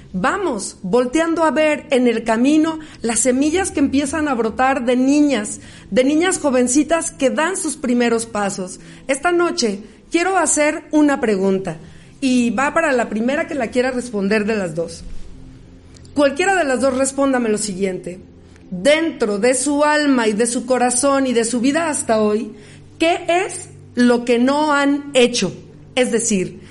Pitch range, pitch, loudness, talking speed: 225-300 Hz, 255 Hz, -17 LUFS, 160 wpm